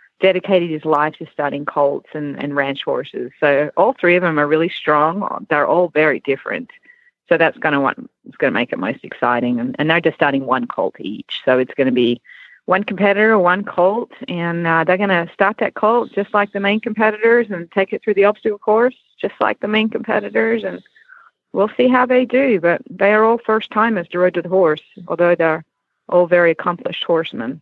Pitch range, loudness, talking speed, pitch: 155-215 Hz, -17 LUFS, 205 wpm, 185 Hz